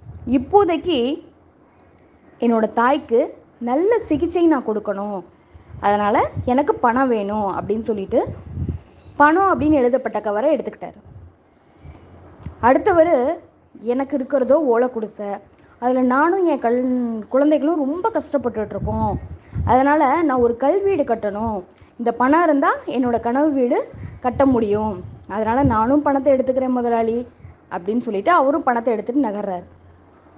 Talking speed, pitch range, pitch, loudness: 105 wpm, 210-290 Hz, 245 Hz, -19 LUFS